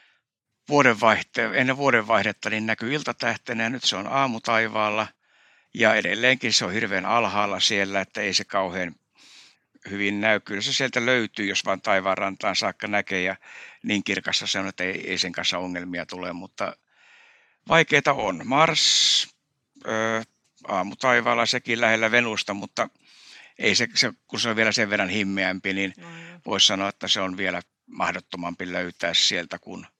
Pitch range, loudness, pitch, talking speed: 95-115 Hz, -23 LUFS, 105 Hz, 155 wpm